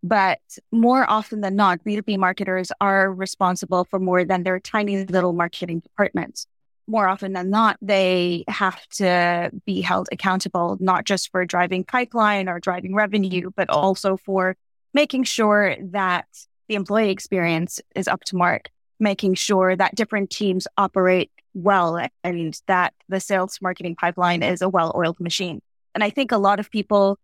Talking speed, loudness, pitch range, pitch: 160 wpm, -21 LUFS, 180-205 Hz, 190 Hz